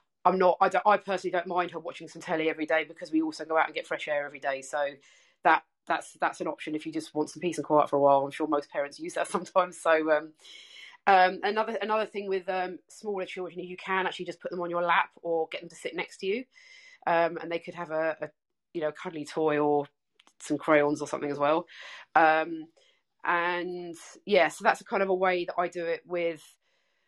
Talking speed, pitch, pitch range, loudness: 245 wpm, 170 Hz, 155-185 Hz, -28 LUFS